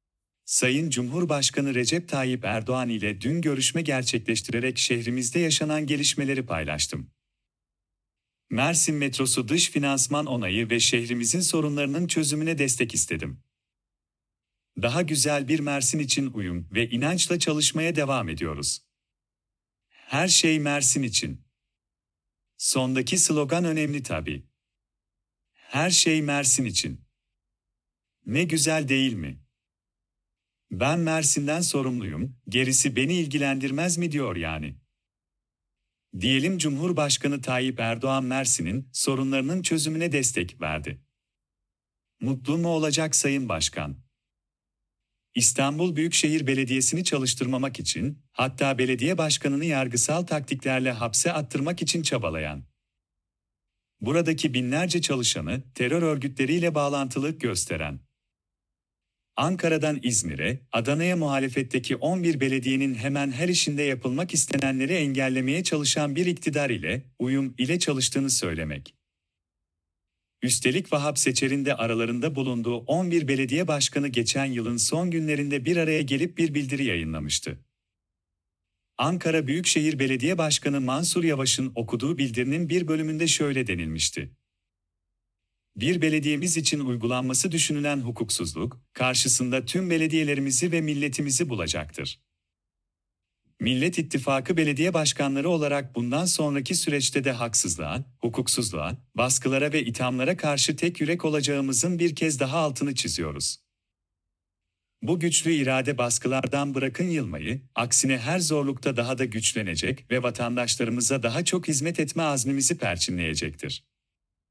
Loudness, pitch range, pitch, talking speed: -25 LUFS, 115-155 Hz, 135 Hz, 105 wpm